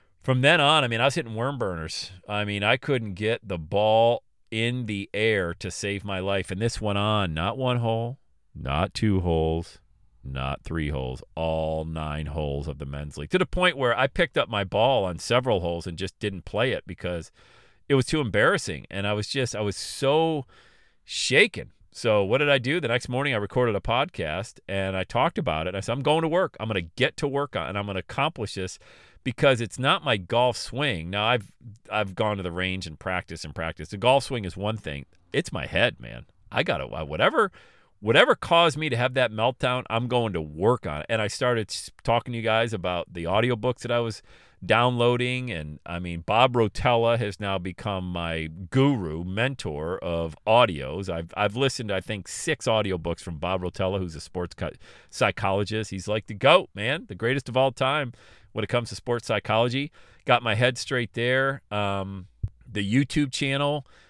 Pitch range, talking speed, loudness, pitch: 90-125 Hz, 210 wpm, -25 LUFS, 105 Hz